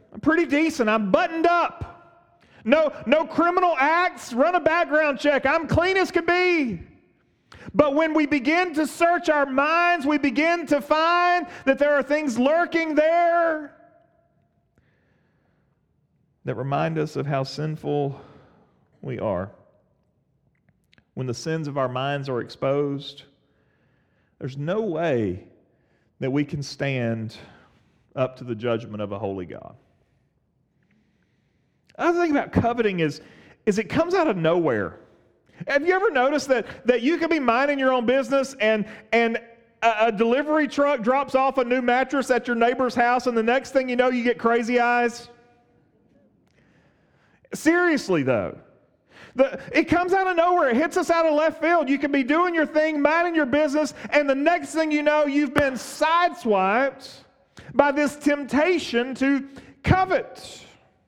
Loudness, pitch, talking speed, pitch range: -22 LUFS, 275 Hz, 155 wpm, 225-320 Hz